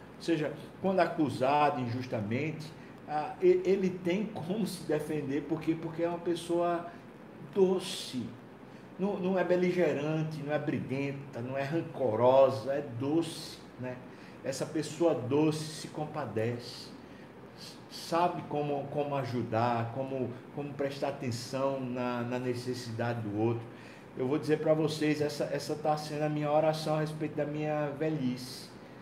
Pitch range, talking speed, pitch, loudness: 130-160 Hz, 130 wpm, 150 Hz, -32 LUFS